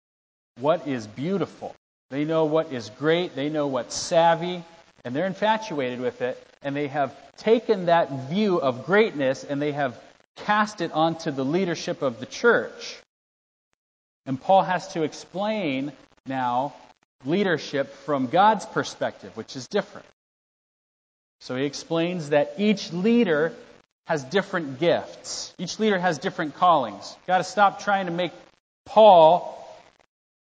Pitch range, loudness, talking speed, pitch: 140-195 Hz, -24 LUFS, 140 wpm, 165 Hz